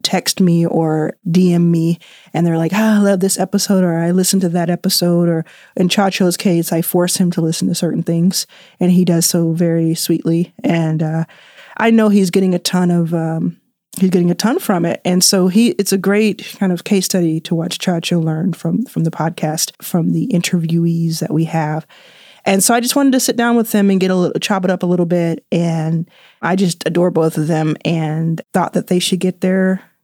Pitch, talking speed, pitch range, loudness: 180 Hz, 220 wpm, 165-195 Hz, -15 LUFS